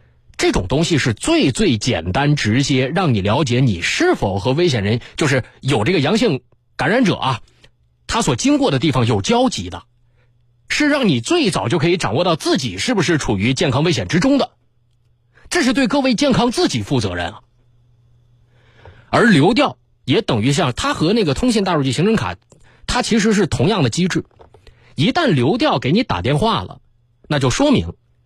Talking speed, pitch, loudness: 265 characters per minute, 130 Hz, -17 LUFS